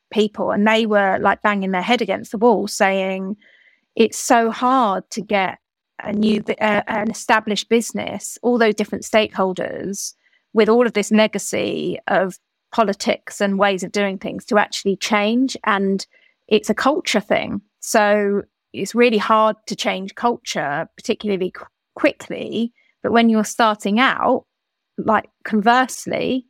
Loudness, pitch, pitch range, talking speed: -19 LUFS, 215 Hz, 200-230 Hz, 145 wpm